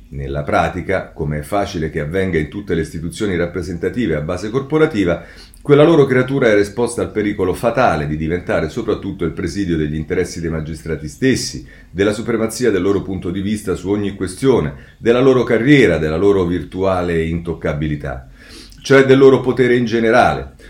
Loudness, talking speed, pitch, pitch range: -16 LUFS, 160 wpm, 95 Hz, 80-115 Hz